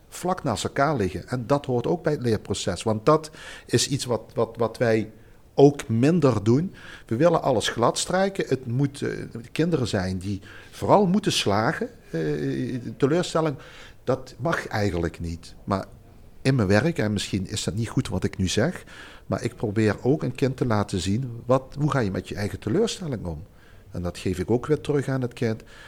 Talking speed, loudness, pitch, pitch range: 190 wpm, -25 LUFS, 120 Hz, 100-140 Hz